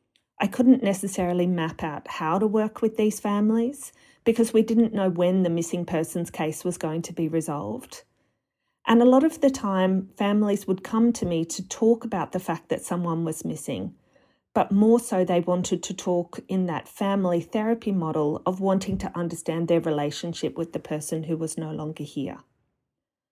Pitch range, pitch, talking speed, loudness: 165-215 Hz, 185 Hz, 185 wpm, -25 LUFS